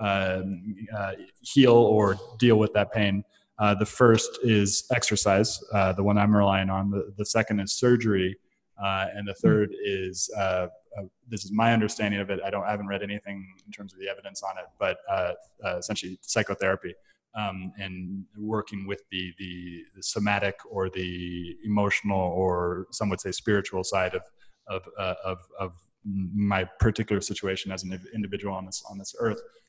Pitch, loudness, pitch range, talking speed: 100 Hz, -27 LUFS, 95-105 Hz, 180 wpm